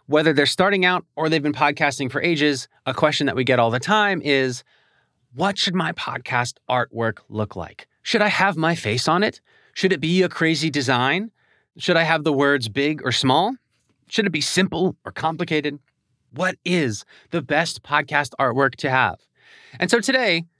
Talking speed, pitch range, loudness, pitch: 185 wpm, 130-175 Hz, -20 LUFS, 150 Hz